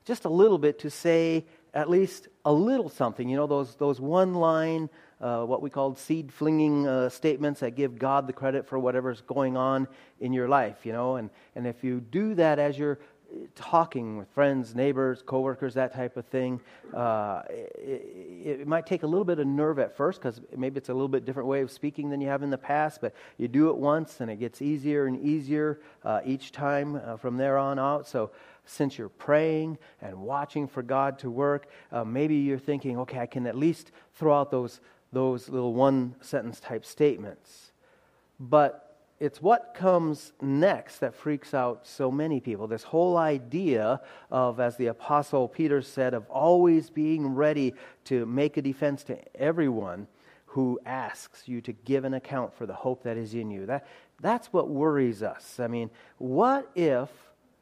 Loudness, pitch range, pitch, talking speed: -28 LUFS, 130-150 Hz, 140 Hz, 195 wpm